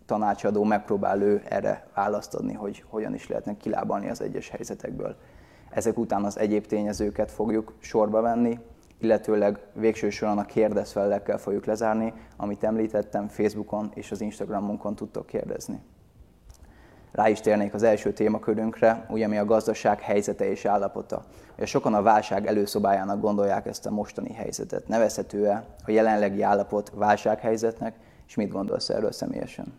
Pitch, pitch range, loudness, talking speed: 105 Hz, 105-110 Hz, -26 LUFS, 135 wpm